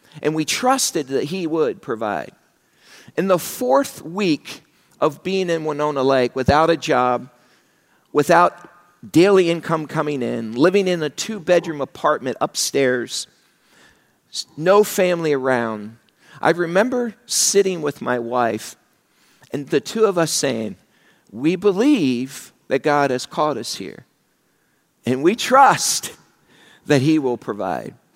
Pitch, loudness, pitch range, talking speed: 155 Hz, -19 LUFS, 130-185 Hz, 130 wpm